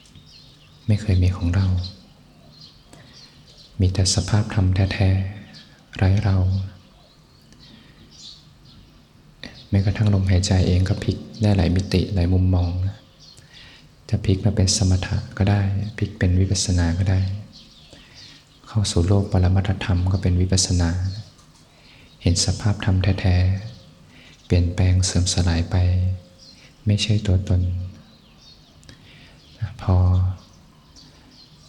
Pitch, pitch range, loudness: 95 Hz, 90-100 Hz, -21 LUFS